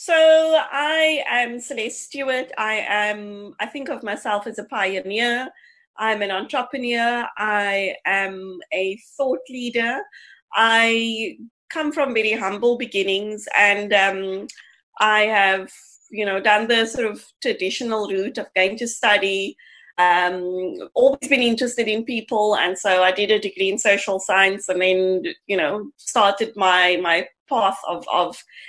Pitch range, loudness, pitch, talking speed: 195-245 Hz, -20 LUFS, 215 Hz, 145 wpm